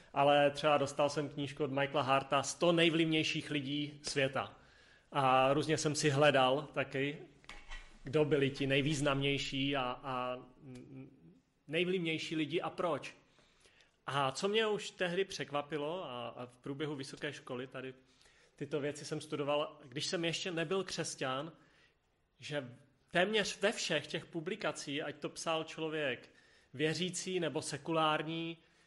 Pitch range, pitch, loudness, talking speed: 135-160 Hz, 150 Hz, -35 LUFS, 130 wpm